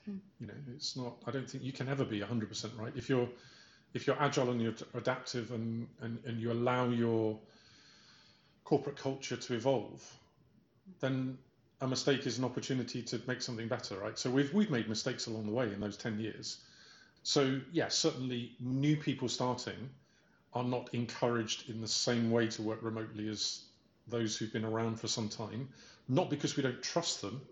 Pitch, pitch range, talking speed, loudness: 125 Hz, 115-130 Hz, 190 wpm, -36 LUFS